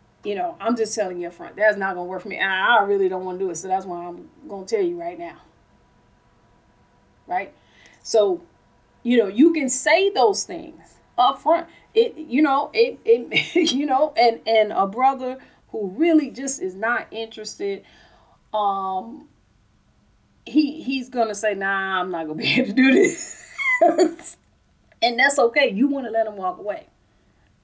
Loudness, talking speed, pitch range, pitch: -21 LUFS, 175 wpm, 195-325 Hz, 255 Hz